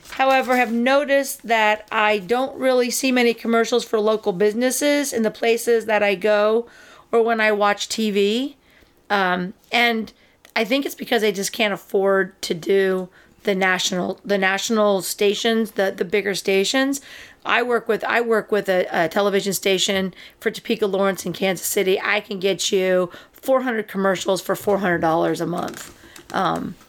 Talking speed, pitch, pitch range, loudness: 165 wpm, 210 Hz, 195-235 Hz, -20 LUFS